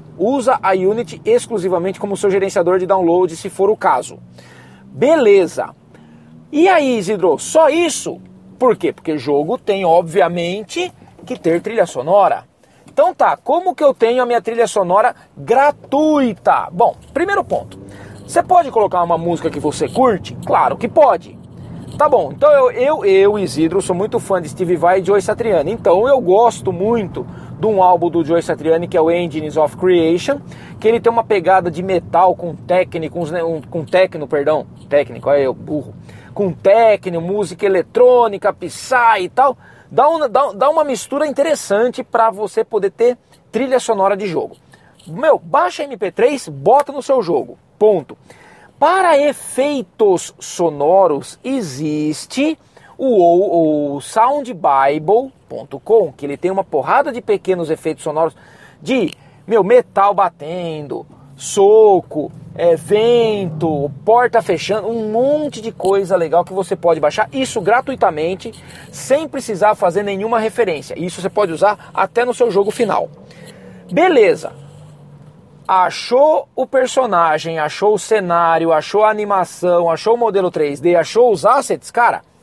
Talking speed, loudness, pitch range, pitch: 145 wpm, -15 LUFS, 170-250 Hz, 200 Hz